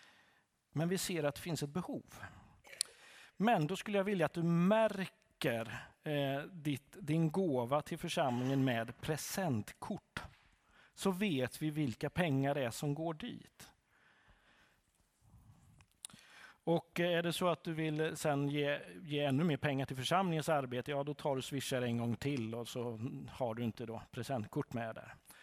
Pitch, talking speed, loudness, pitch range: 145 Hz, 155 wpm, -37 LUFS, 130-170 Hz